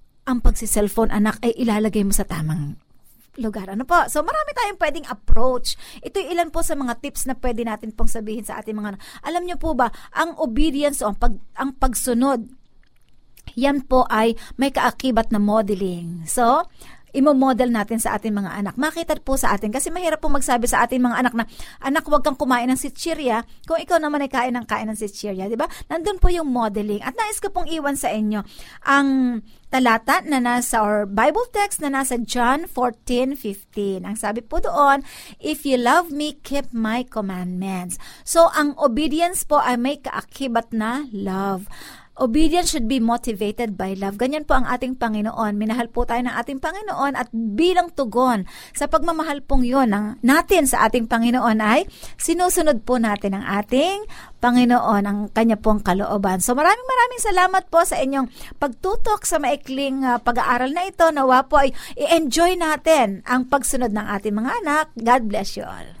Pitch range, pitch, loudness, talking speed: 220-300 Hz, 250 Hz, -21 LUFS, 180 wpm